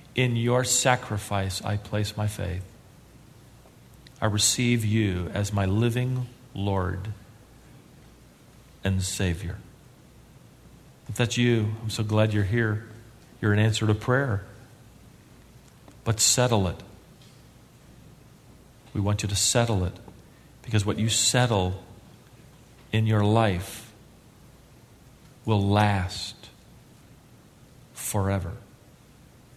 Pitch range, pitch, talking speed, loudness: 100-120 Hz, 110 Hz, 95 wpm, -25 LUFS